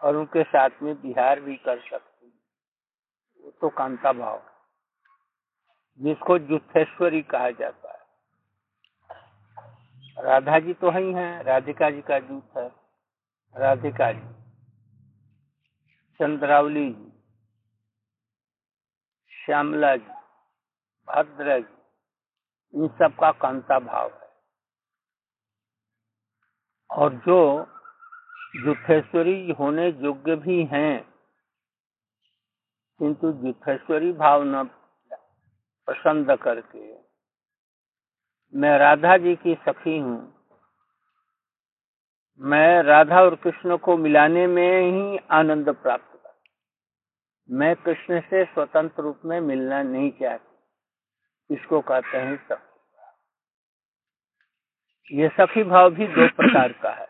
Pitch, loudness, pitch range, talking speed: 150 Hz, -21 LUFS, 130-170 Hz, 95 wpm